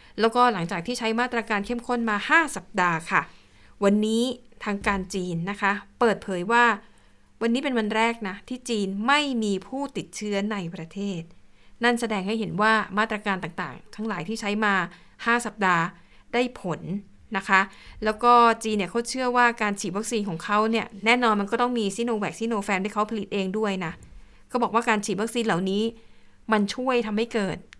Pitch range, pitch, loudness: 195-235 Hz, 215 Hz, -25 LUFS